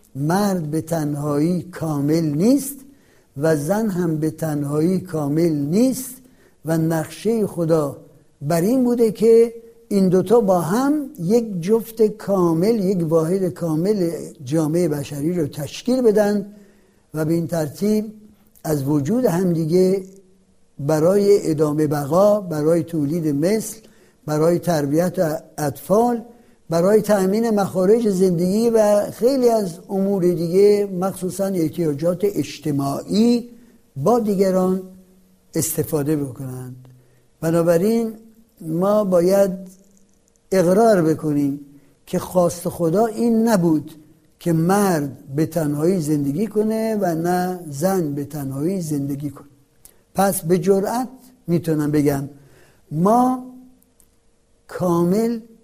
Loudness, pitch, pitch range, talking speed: -19 LUFS, 180 Hz, 155-210 Hz, 105 wpm